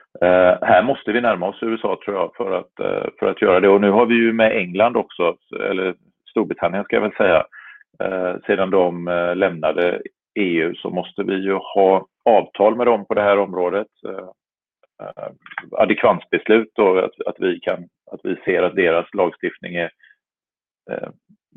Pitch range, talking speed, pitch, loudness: 90-105 Hz, 175 wpm, 95 Hz, -18 LUFS